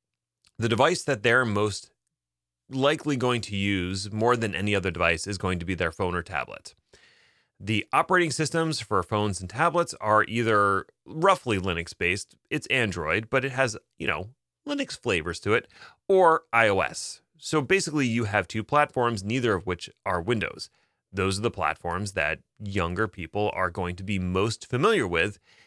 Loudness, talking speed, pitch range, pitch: -26 LUFS, 170 wpm, 95-135 Hz, 105 Hz